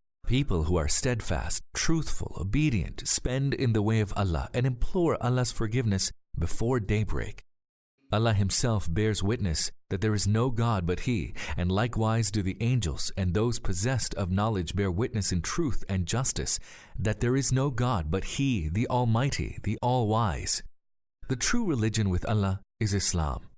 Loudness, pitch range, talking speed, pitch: -28 LUFS, 95-125 Hz, 165 wpm, 110 Hz